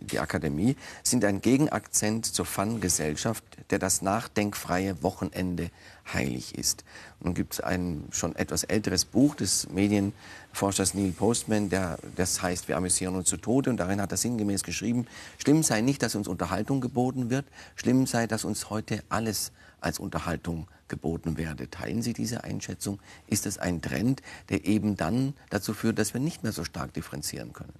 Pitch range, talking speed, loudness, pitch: 90-115 Hz, 170 wpm, -28 LUFS, 100 Hz